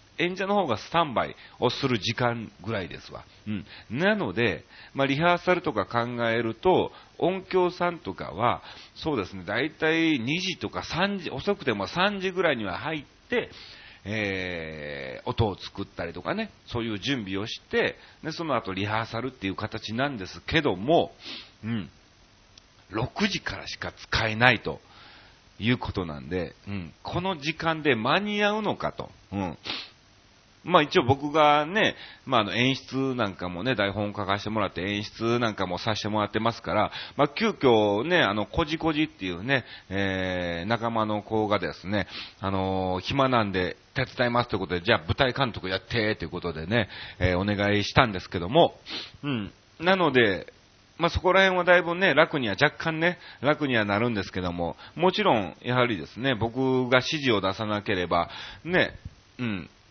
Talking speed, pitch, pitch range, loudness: 325 characters per minute, 115 Hz, 100-150 Hz, -26 LUFS